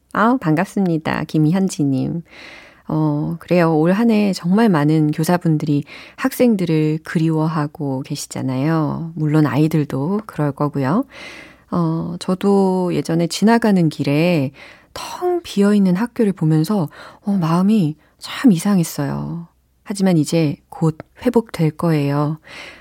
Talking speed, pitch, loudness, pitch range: 255 characters per minute, 165 Hz, -18 LUFS, 155-200 Hz